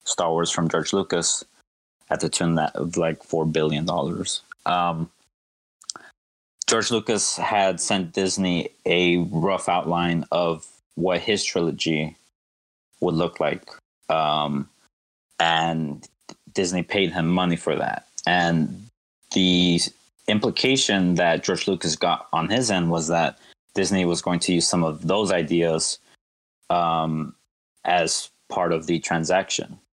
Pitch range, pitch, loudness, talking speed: 80-90 Hz, 85 Hz, -23 LUFS, 130 wpm